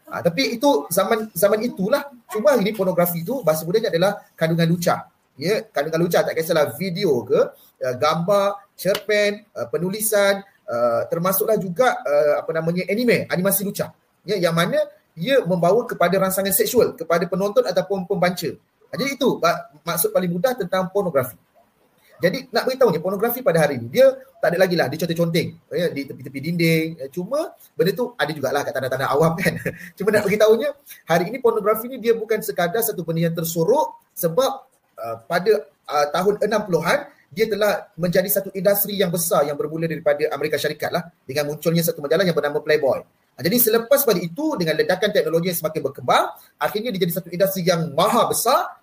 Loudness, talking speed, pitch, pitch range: -21 LUFS, 170 wpm, 185 Hz, 165-215 Hz